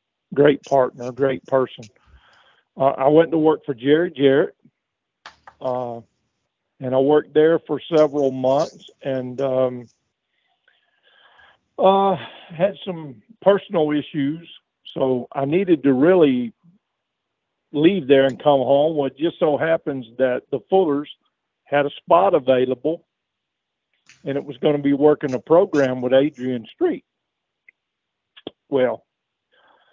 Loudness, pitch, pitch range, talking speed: -19 LUFS, 145 Hz, 130-165 Hz, 125 wpm